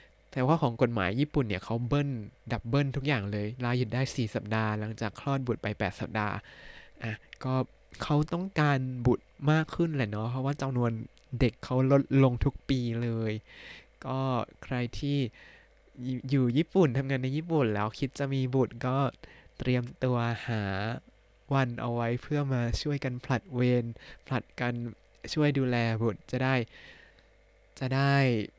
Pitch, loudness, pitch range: 125 Hz, -30 LUFS, 115-140 Hz